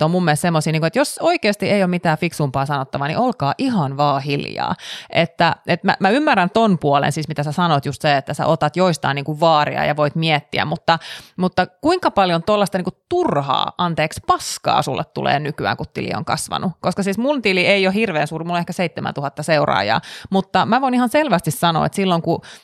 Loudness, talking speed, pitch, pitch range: -18 LUFS, 205 wpm, 175 Hz, 155-200 Hz